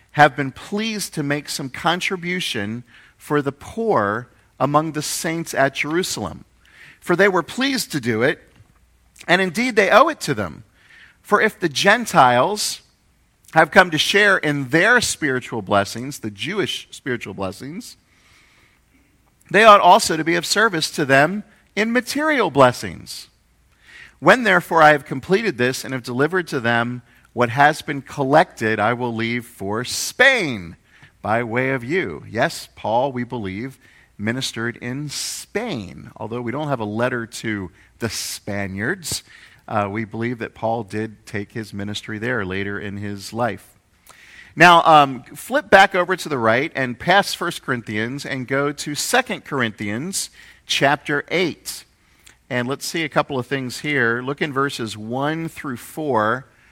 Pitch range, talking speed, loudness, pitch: 115-165 Hz, 150 wpm, -19 LUFS, 135 Hz